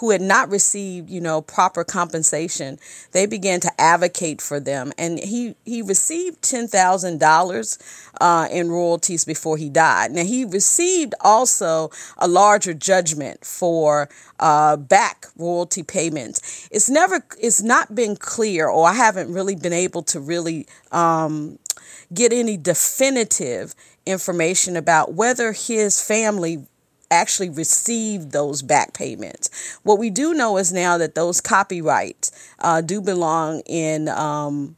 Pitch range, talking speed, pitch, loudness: 160-210 Hz, 140 wpm, 180 Hz, -19 LUFS